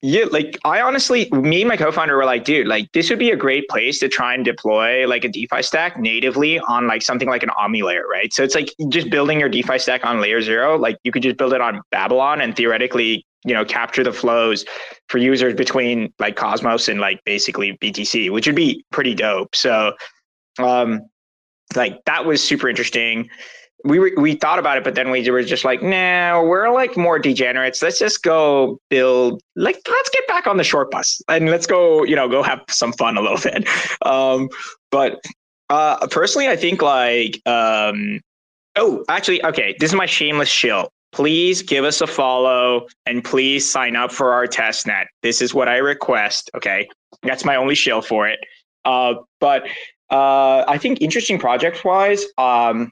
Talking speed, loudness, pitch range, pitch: 195 wpm, -17 LUFS, 120-175 Hz, 130 Hz